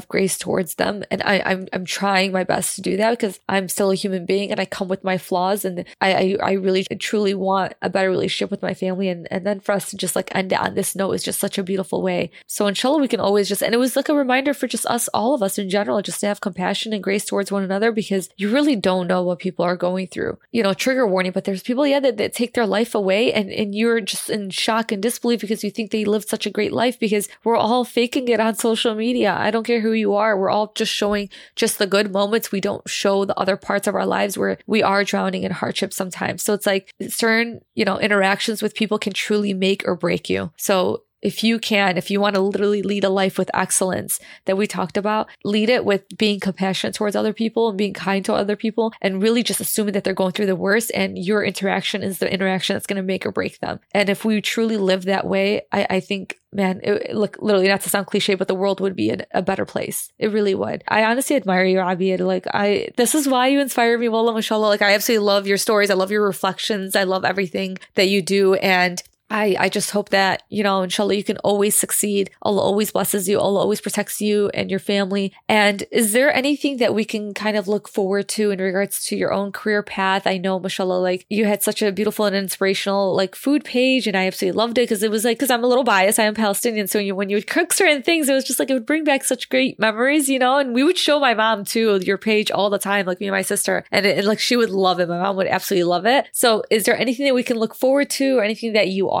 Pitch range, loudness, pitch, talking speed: 195-225 Hz, -20 LUFS, 205 Hz, 265 wpm